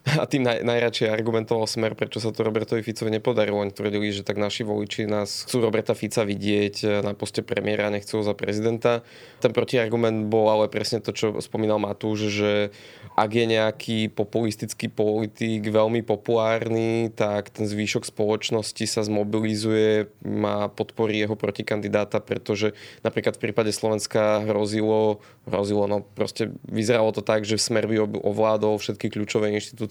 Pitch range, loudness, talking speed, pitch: 105-115 Hz, -24 LUFS, 155 wpm, 110 Hz